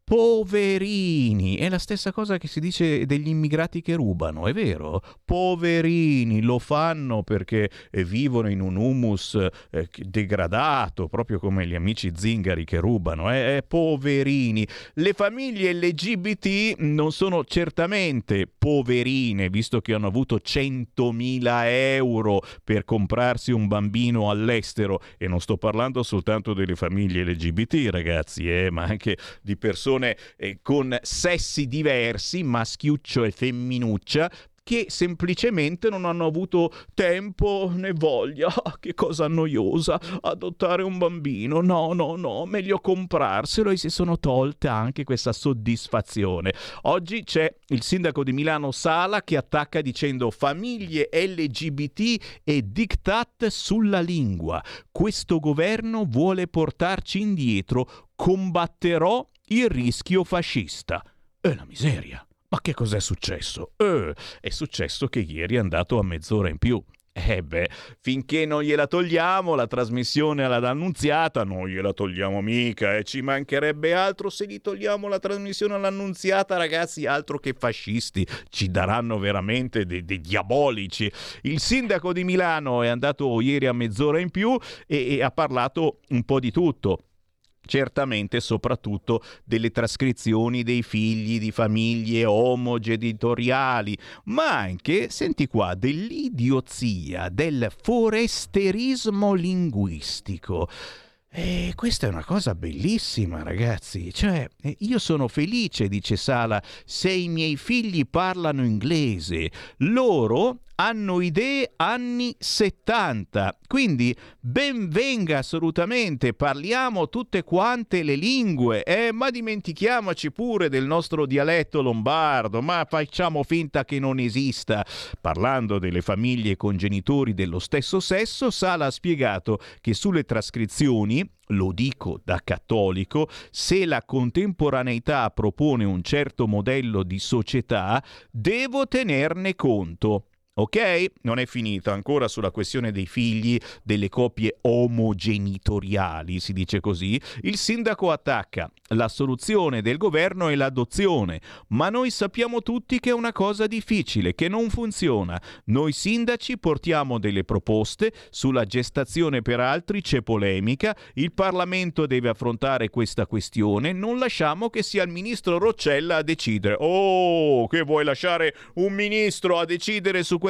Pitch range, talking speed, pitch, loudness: 110-180 Hz, 125 wpm, 135 Hz, -24 LUFS